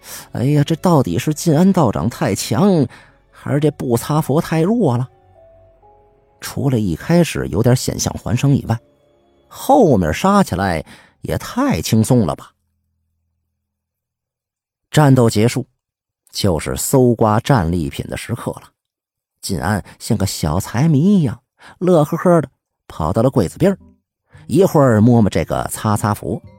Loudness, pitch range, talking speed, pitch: -16 LUFS, 105-145 Hz, 200 characters per minute, 125 Hz